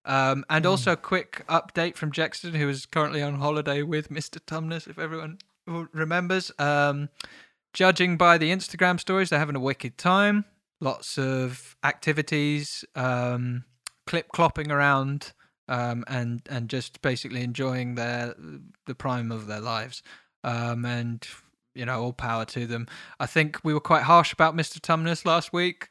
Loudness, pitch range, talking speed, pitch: -26 LUFS, 125-165 Hz, 160 wpm, 145 Hz